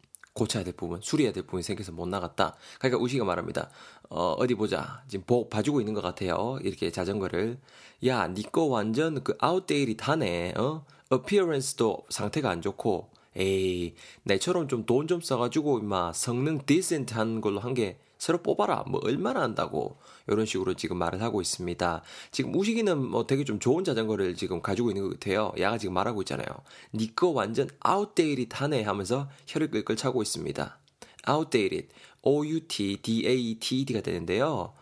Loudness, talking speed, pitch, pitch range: -29 LUFS, 380 characters per minute, 120 Hz, 105-140 Hz